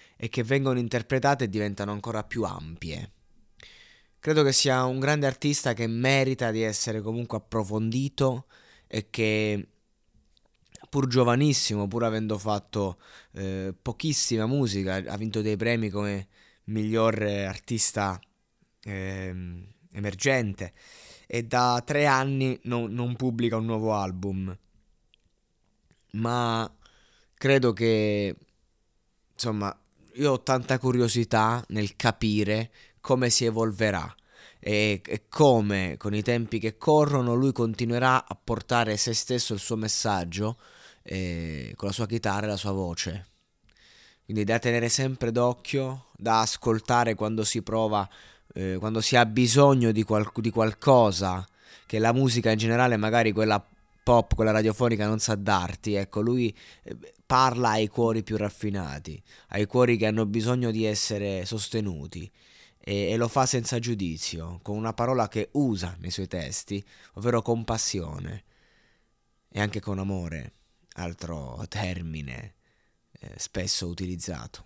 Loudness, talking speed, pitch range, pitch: -26 LUFS, 130 wpm, 100-120 Hz, 110 Hz